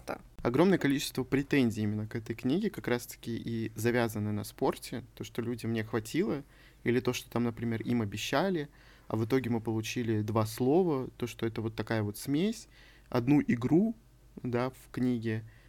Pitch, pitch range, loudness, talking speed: 120 Hz, 115-130 Hz, -32 LUFS, 170 wpm